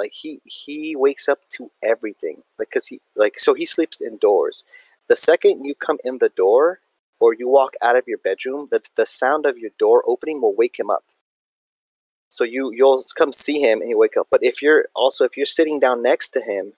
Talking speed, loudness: 220 wpm, -17 LUFS